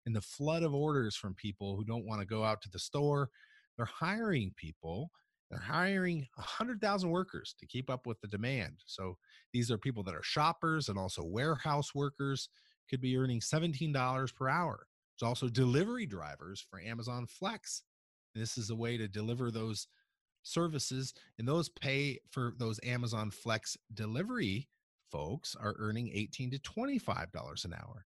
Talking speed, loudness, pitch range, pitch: 165 wpm, -37 LUFS, 110-150 Hz, 125 Hz